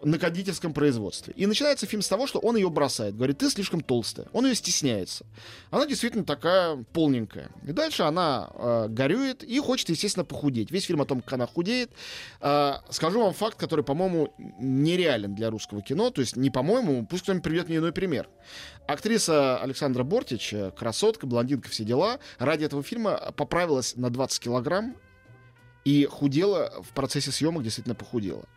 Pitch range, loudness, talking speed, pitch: 120-190 Hz, -27 LUFS, 170 wpm, 145 Hz